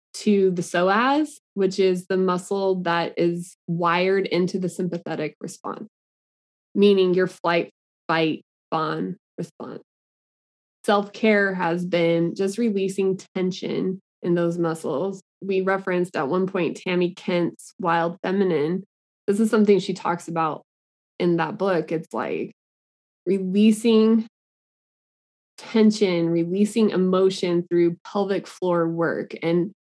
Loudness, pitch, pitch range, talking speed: -23 LUFS, 185 Hz, 170-195 Hz, 115 wpm